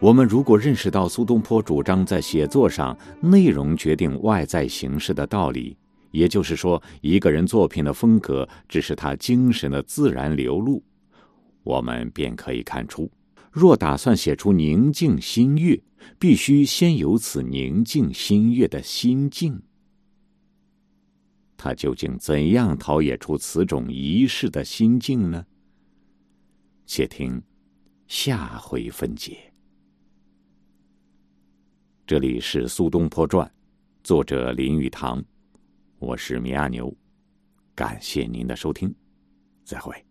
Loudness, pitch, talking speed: -21 LUFS, 90 Hz, 185 characters per minute